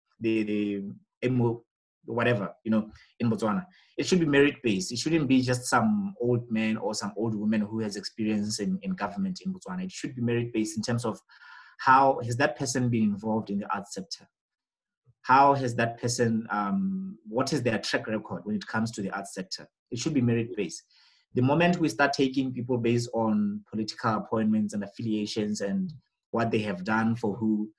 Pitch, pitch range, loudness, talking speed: 120 Hz, 110-140 Hz, -28 LUFS, 190 wpm